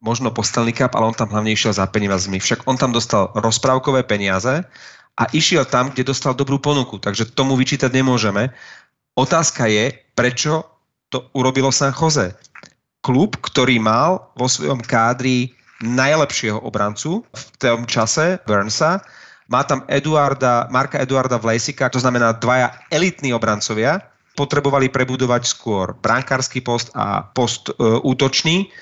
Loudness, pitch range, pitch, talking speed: -18 LUFS, 115-135 Hz, 125 Hz, 135 wpm